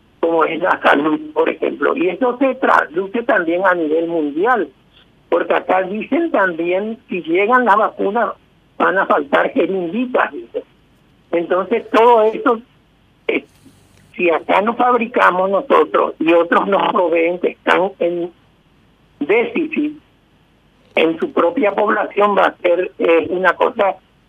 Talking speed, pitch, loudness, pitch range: 130 wpm, 210 Hz, -16 LUFS, 180-265 Hz